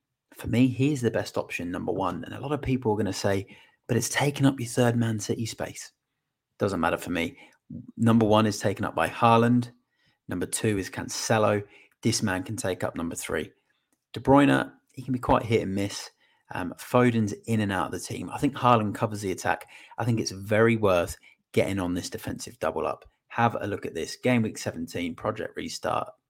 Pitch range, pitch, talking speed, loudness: 105-125 Hz, 115 Hz, 210 wpm, -27 LUFS